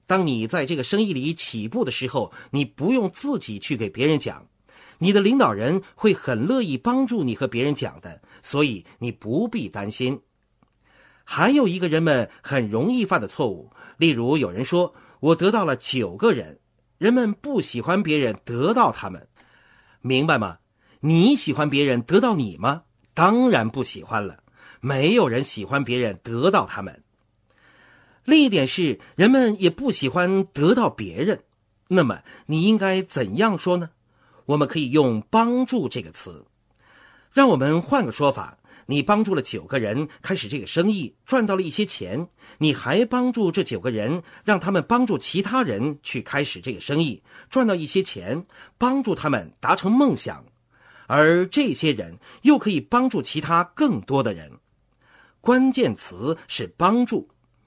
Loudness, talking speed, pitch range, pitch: -22 LUFS, 235 characters per minute, 130-210 Hz, 165 Hz